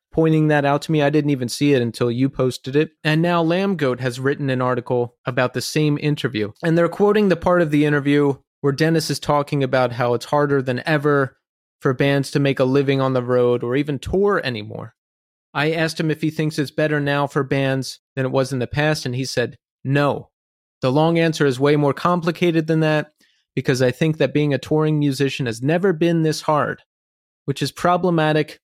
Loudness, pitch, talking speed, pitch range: -19 LUFS, 145 Hz, 215 wpm, 130-155 Hz